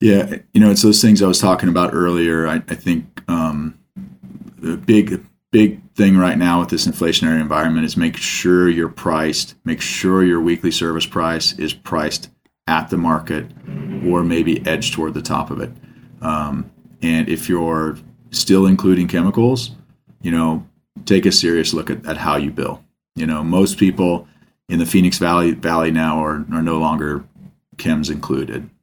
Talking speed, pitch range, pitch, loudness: 175 wpm, 80-95 Hz, 85 Hz, -17 LUFS